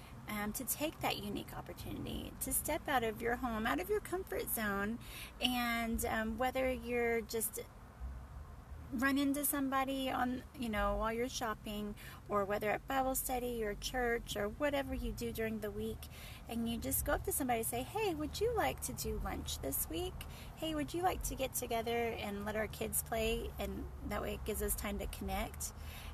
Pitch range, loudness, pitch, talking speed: 220-265 Hz, -38 LUFS, 235 Hz, 195 wpm